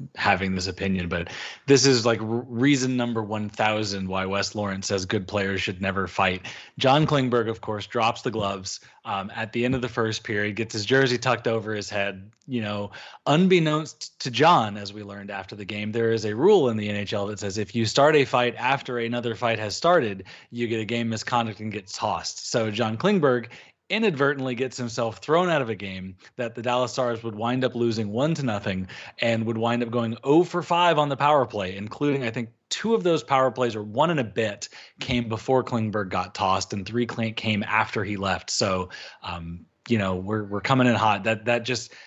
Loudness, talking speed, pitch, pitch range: -24 LUFS, 215 wpm, 115 Hz, 105-125 Hz